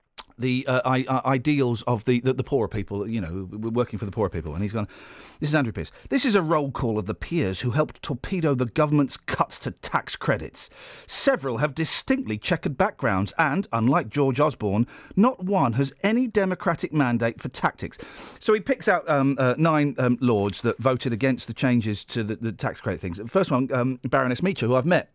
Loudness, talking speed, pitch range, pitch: -24 LUFS, 205 wpm, 115-155 Hz, 130 Hz